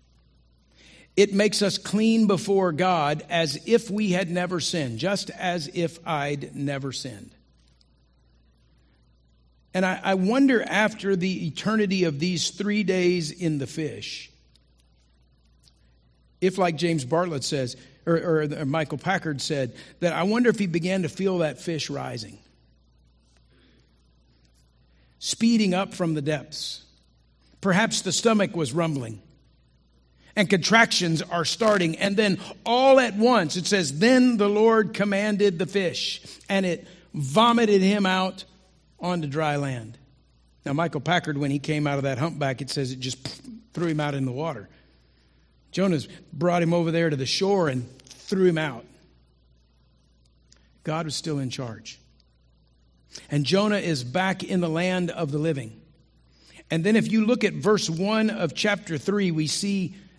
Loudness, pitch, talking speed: -24 LUFS, 160 Hz, 150 wpm